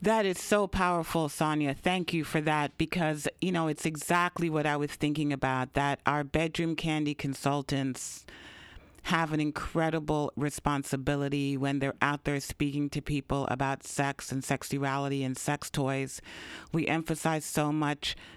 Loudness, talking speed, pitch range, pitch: -30 LUFS, 150 wpm, 140-160 Hz, 145 Hz